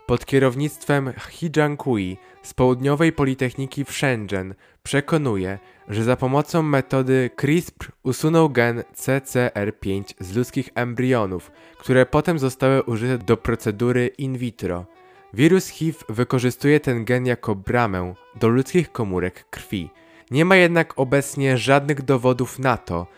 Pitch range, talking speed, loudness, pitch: 115-145 Hz, 120 wpm, -21 LUFS, 130 Hz